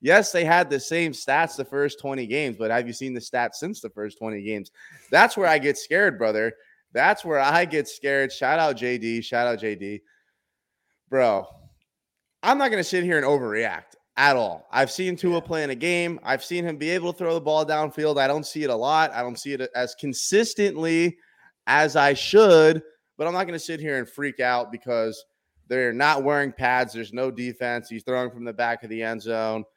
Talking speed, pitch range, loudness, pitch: 220 wpm, 120-165 Hz, -23 LUFS, 140 Hz